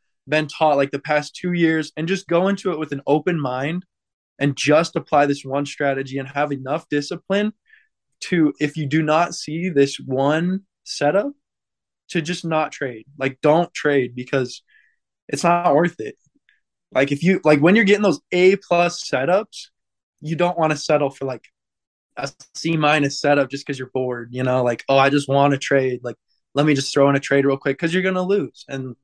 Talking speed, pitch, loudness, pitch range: 205 wpm, 150 Hz, -20 LUFS, 140-170 Hz